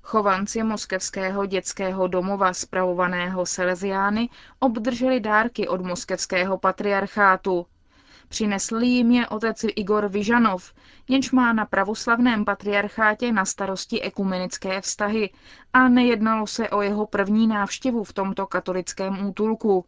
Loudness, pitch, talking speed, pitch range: -23 LUFS, 200 Hz, 110 wpm, 190-225 Hz